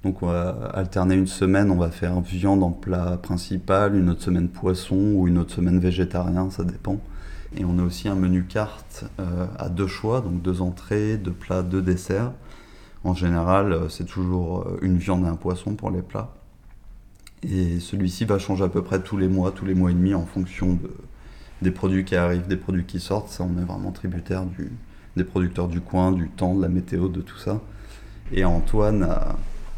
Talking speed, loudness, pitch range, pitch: 205 wpm, -24 LUFS, 90-100 Hz, 95 Hz